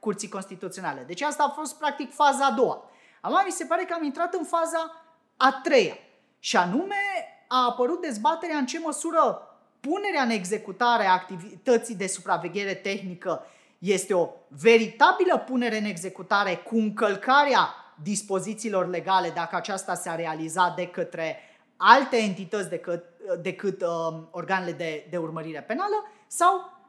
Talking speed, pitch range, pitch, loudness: 145 wpm, 185-300 Hz, 215 Hz, -25 LUFS